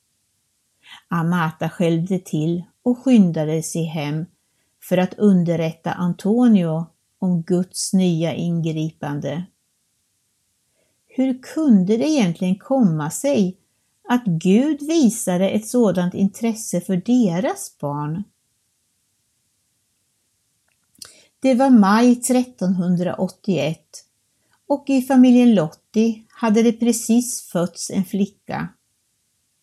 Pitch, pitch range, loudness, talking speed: 185 Hz, 165-230 Hz, -19 LUFS, 90 wpm